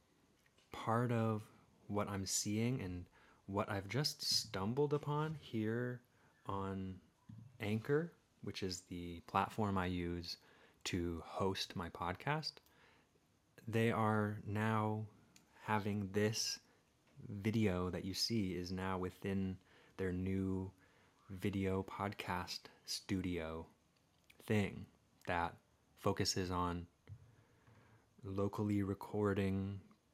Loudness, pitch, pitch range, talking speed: -40 LUFS, 100 Hz, 95-110 Hz, 95 wpm